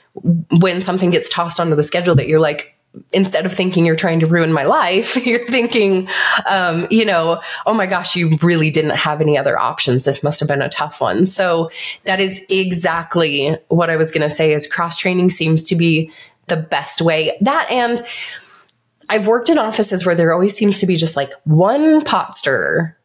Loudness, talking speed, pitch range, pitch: -15 LUFS, 200 wpm, 160-190 Hz, 170 Hz